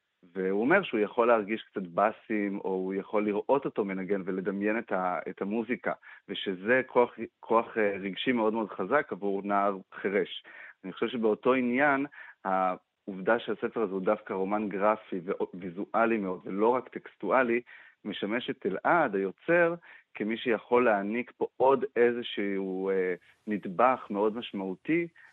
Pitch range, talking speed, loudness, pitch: 95-115 Hz, 130 wpm, -29 LUFS, 105 Hz